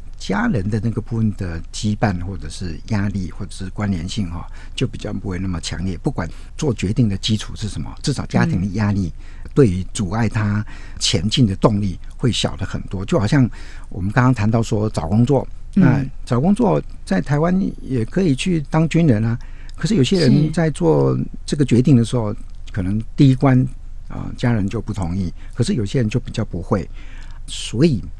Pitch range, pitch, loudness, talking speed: 95-130 Hz, 105 Hz, -19 LUFS, 275 characters per minute